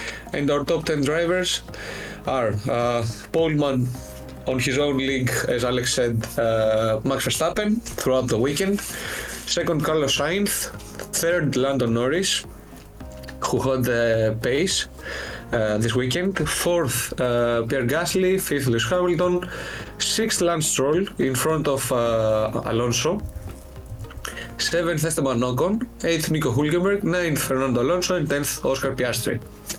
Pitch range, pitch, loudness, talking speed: 120-170 Hz, 135 Hz, -22 LUFS, 125 wpm